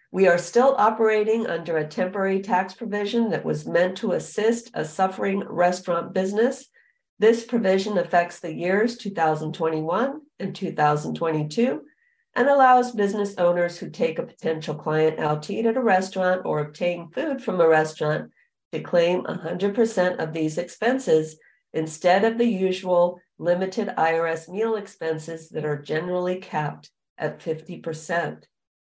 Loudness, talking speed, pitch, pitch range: -23 LUFS, 140 wpm, 180 Hz, 165-220 Hz